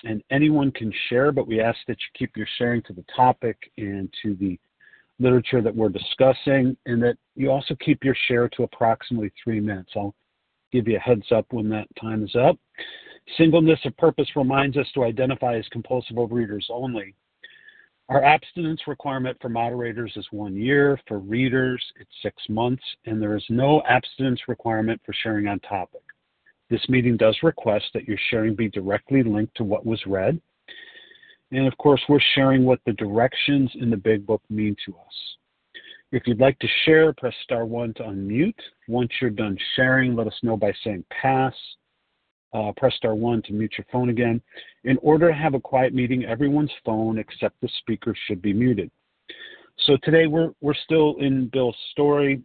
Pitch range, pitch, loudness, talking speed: 110-135 Hz, 125 Hz, -22 LUFS, 180 wpm